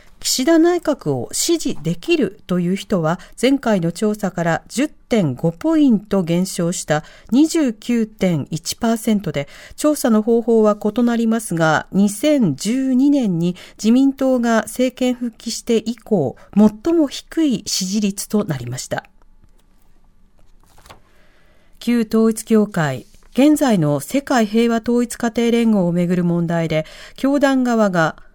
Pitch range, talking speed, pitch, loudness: 175-250 Hz, 210 characters per minute, 220 Hz, -18 LUFS